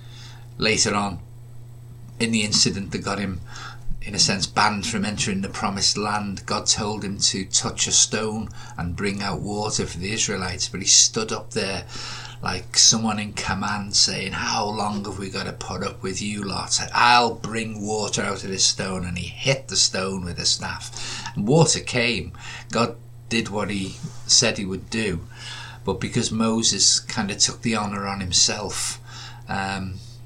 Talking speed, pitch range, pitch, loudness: 175 wpm, 100-120 Hz, 110 Hz, -21 LUFS